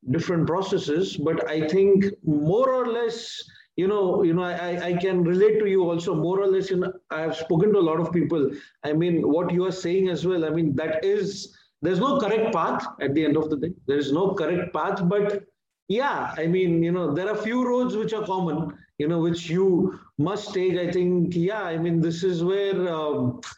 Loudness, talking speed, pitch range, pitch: -24 LUFS, 220 wpm, 165-195 Hz, 180 Hz